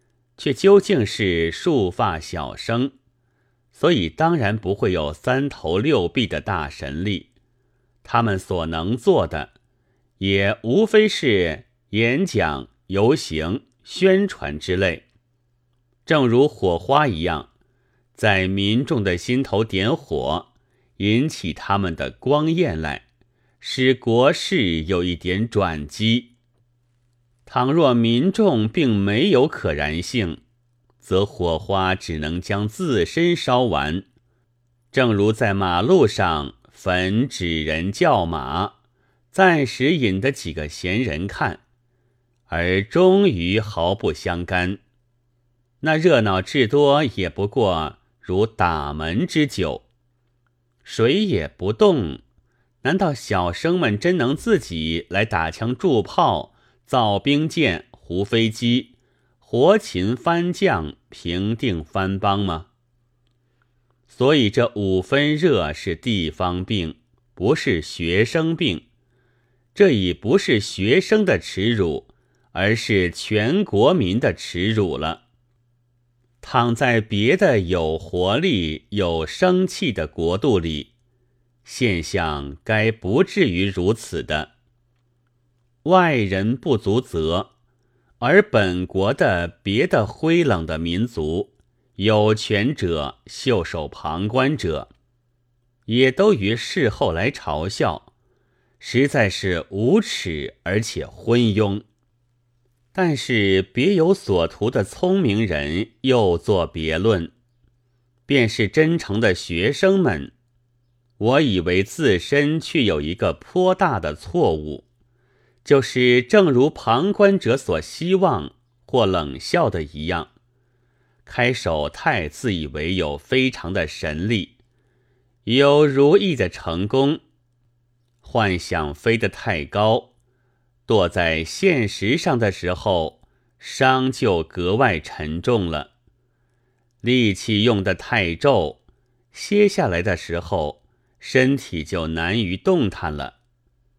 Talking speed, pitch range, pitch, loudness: 155 characters per minute, 95-125 Hz, 120 Hz, -20 LUFS